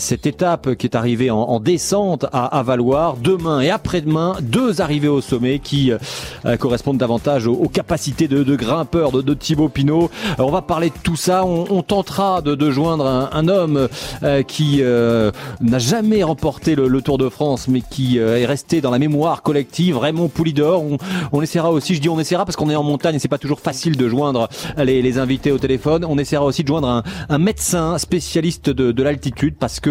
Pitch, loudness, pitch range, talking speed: 145 Hz, -17 LUFS, 130-165 Hz, 215 wpm